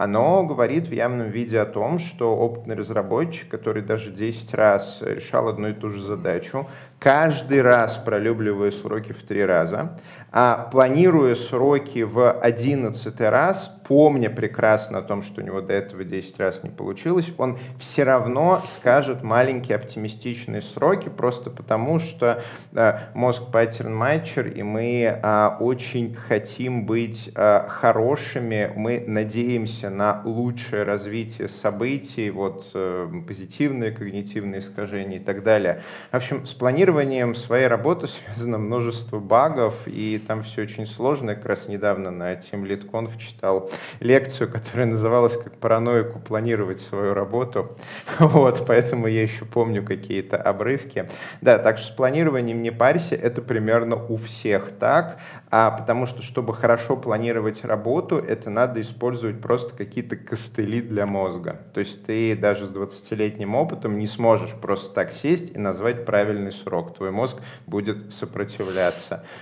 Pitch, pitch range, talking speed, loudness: 115 Hz, 105-125 Hz, 140 wpm, -22 LUFS